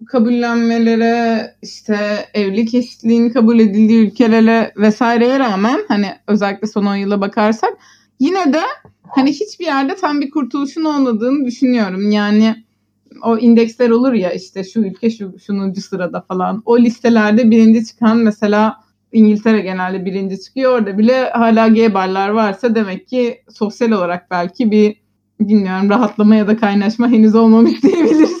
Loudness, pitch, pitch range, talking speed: -14 LUFS, 225 Hz, 210-240 Hz, 140 wpm